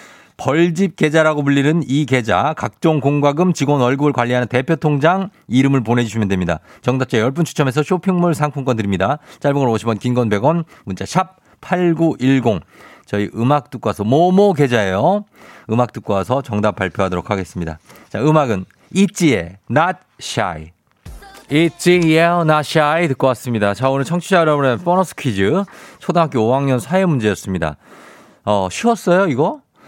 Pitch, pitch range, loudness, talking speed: 135 Hz, 115-165 Hz, -16 LUFS, 320 characters per minute